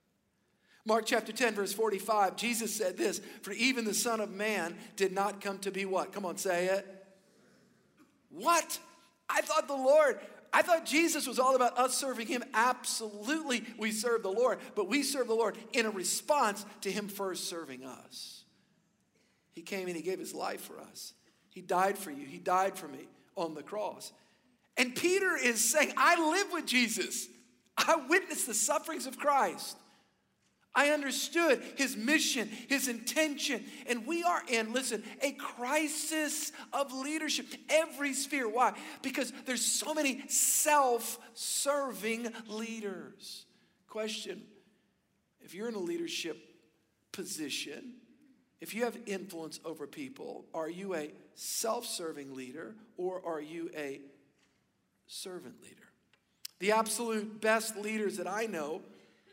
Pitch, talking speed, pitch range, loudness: 230 Hz, 150 wpm, 200-280 Hz, -32 LUFS